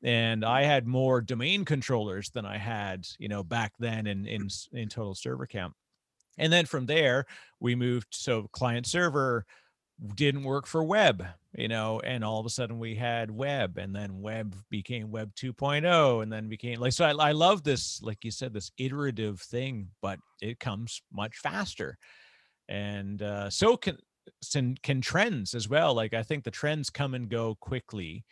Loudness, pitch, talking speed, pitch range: -30 LUFS, 120 Hz, 180 wpm, 105-135 Hz